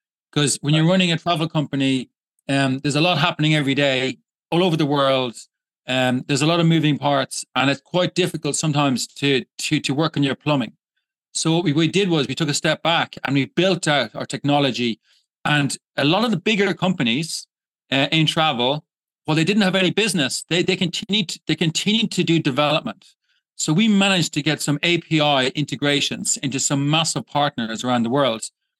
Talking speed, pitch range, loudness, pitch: 195 wpm, 140-175 Hz, -20 LUFS, 155 Hz